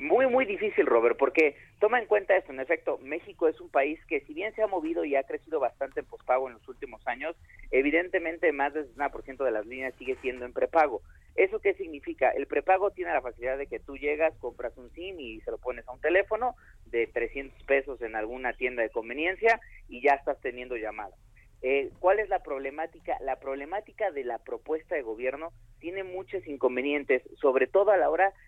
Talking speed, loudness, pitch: 205 wpm, -29 LUFS, 185 Hz